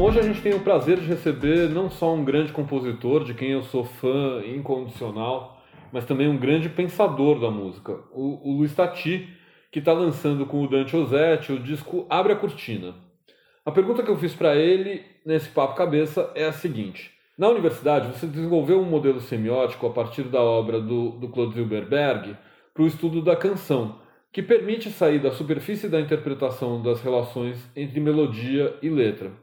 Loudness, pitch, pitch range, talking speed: -23 LUFS, 145 Hz, 125-170 Hz, 175 wpm